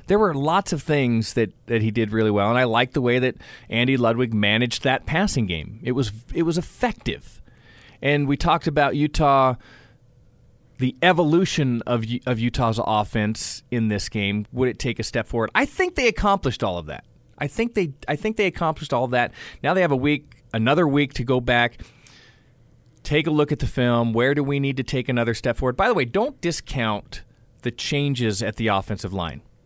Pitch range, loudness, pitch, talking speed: 115-145 Hz, -22 LUFS, 125 Hz, 205 wpm